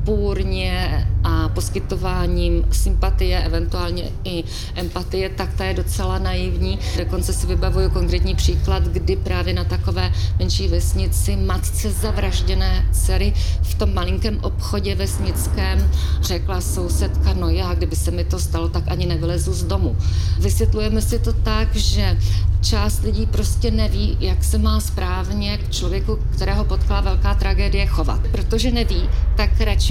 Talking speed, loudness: 140 wpm, -21 LUFS